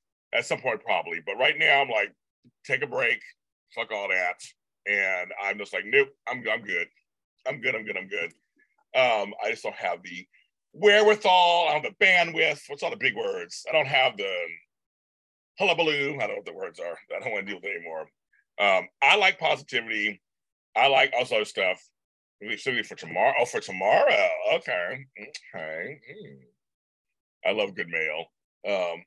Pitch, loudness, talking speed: 325 Hz, -25 LUFS, 190 wpm